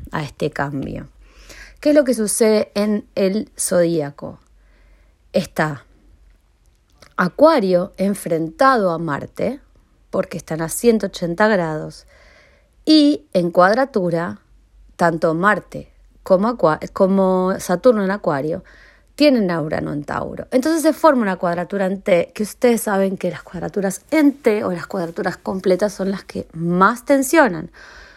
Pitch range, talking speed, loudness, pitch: 165-220 Hz, 130 wpm, -18 LUFS, 190 Hz